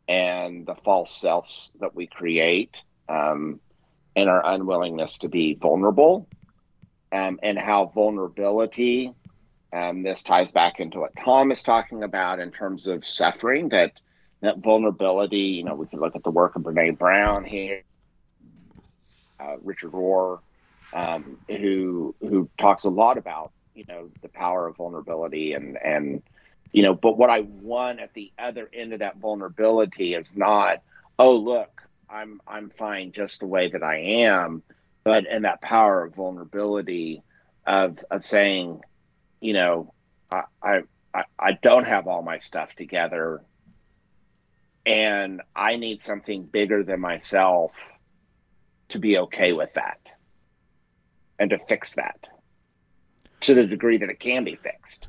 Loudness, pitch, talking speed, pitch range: -23 LUFS, 100 Hz, 150 wpm, 85-110 Hz